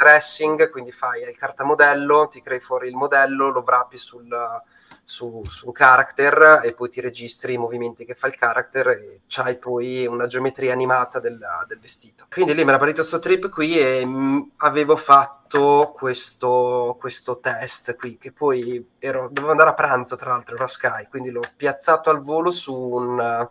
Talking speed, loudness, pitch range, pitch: 175 wpm, -19 LUFS, 125-150 Hz, 130 Hz